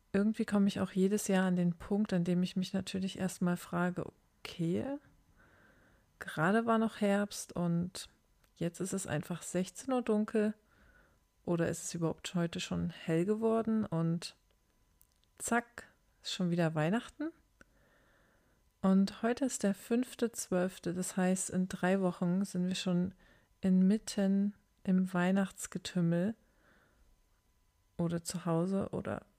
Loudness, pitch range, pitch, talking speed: -34 LUFS, 175-205 Hz, 185 Hz, 130 wpm